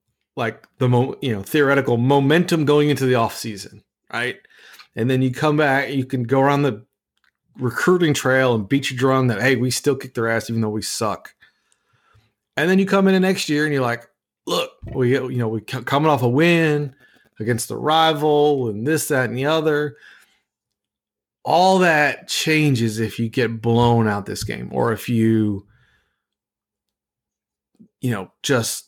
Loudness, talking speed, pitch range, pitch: -19 LUFS, 170 wpm, 115-150 Hz, 130 Hz